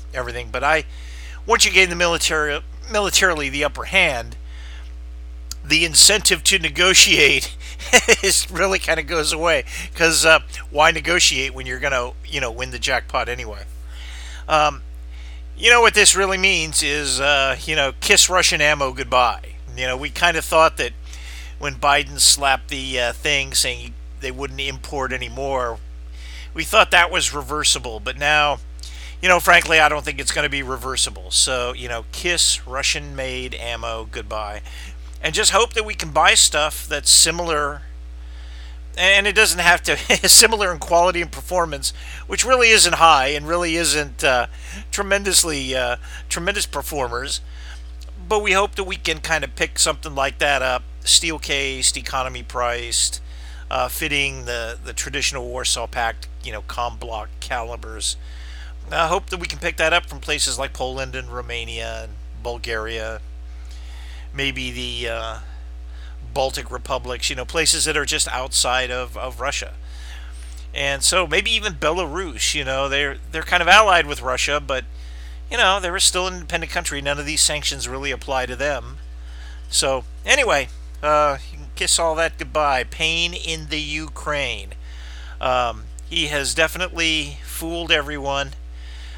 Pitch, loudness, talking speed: 120 Hz, -18 LUFS, 155 wpm